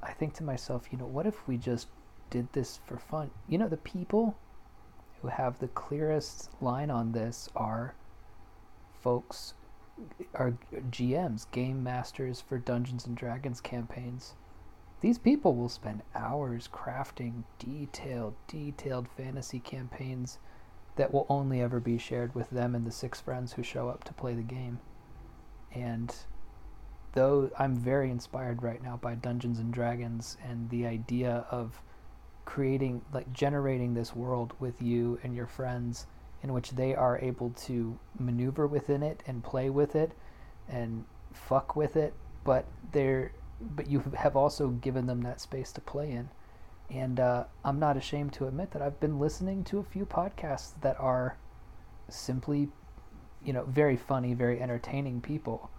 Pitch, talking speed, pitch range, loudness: 125 Hz, 155 wpm, 120-135 Hz, -33 LUFS